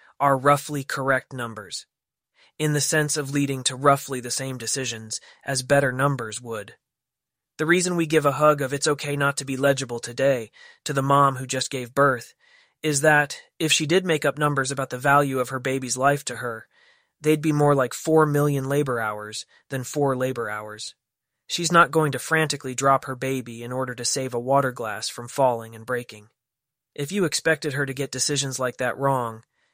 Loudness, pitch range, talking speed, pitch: -23 LUFS, 125-145 Hz, 195 wpm, 135 Hz